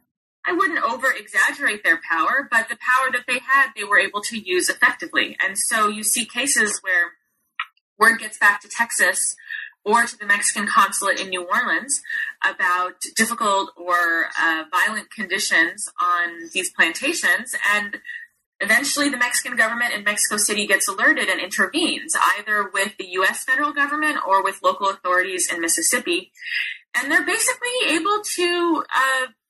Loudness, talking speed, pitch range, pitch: -19 LUFS, 155 wpm, 205-330 Hz, 245 Hz